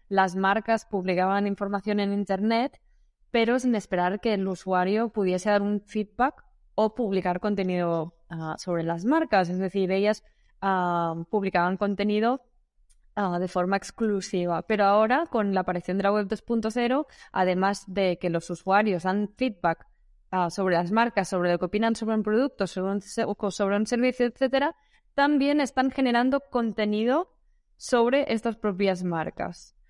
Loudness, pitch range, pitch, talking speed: -26 LUFS, 185-230 Hz, 200 Hz, 150 wpm